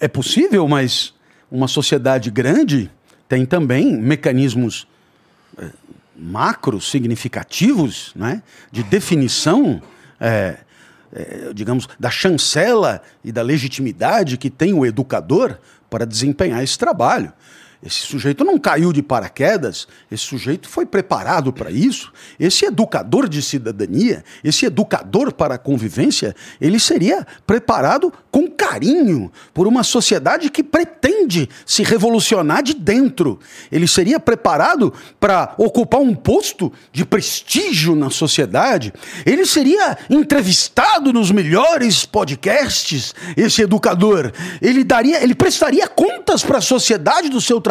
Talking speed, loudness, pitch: 120 wpm, -16 LUFS, 190 Hz